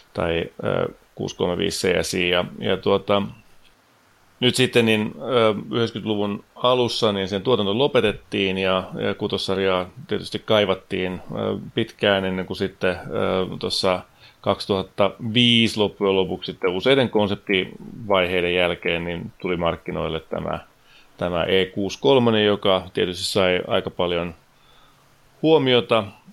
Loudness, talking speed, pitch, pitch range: -22 LUFS, 95 wpm, 95 Hz, 90-110 Hz